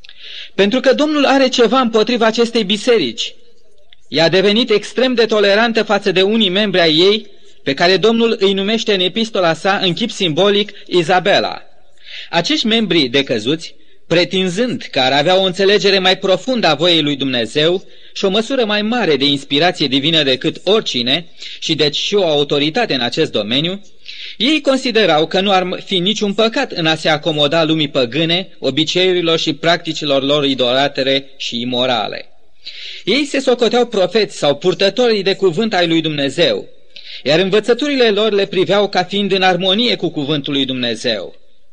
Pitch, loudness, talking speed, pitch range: 190 Hz, -14 LUFS, 160 wpm, 160-220 Hz